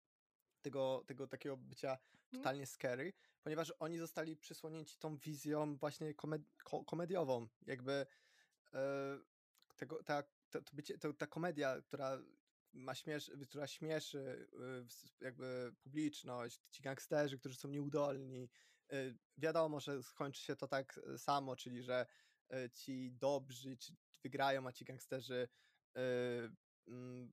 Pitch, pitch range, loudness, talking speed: 140 Hz, 130-150 Hz, -46 LUFS, 110 wpm